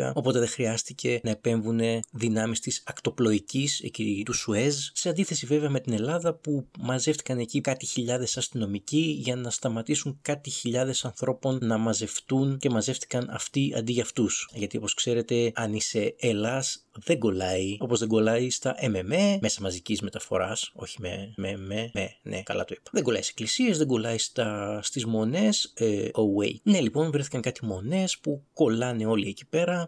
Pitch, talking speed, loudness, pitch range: 120 Hz, 165 wpm, -28 LUFS, 110-140 Hz